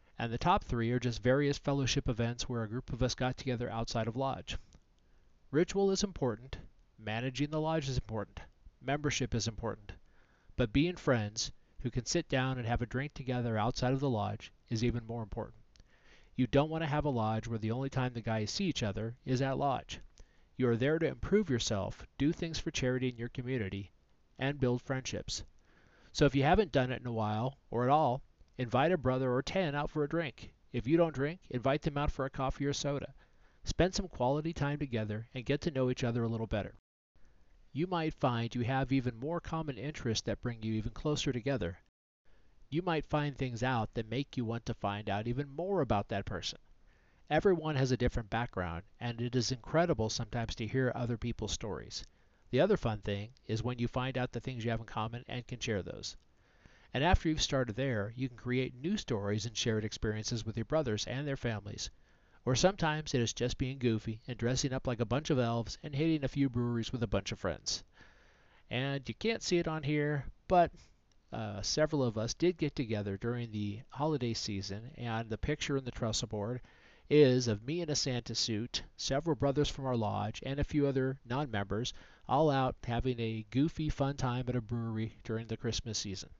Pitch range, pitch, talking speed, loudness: 110-140 Hz, 125 Hz, 210 wpm, -34 LUFS